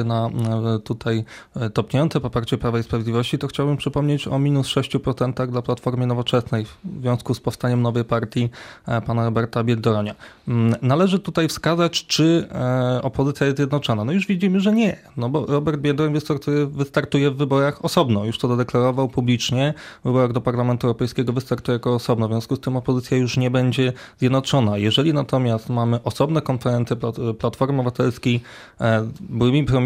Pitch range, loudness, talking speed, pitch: 120-140 Hz, -21 LUFS, 155 wpm, 125 Hz